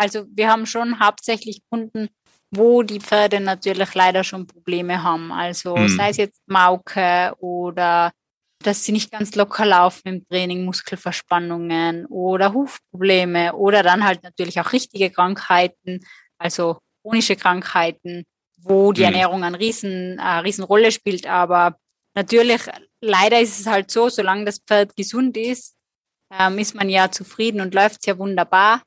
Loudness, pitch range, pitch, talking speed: -18 LUFS, 180-210 Hz, 195 Hz, 145 wpm